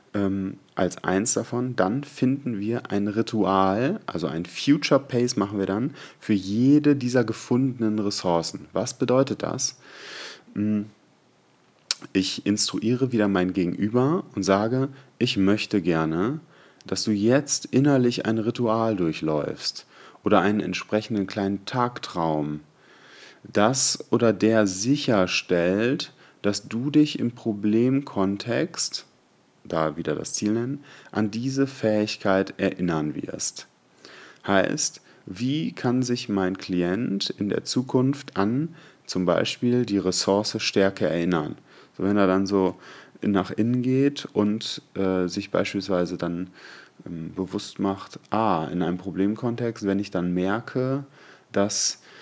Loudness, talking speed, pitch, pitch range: -24 LUFS, 120 wpm, 105 Hz, 95-125 Hz